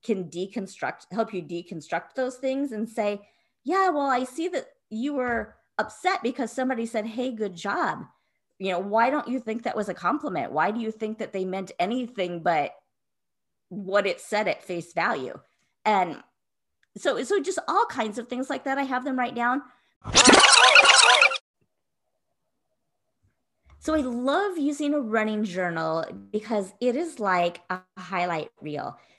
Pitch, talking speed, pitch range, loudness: 225 Hz, 160 wpm, 190-260 Hz, -24 LUFS